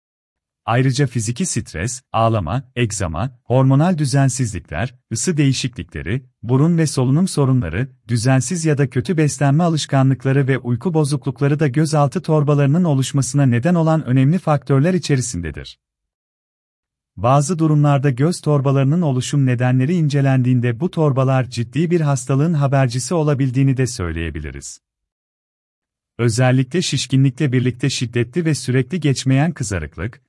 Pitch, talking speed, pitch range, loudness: 135 Hz, 110 wpm, 120-150 Hz, -18 LUFS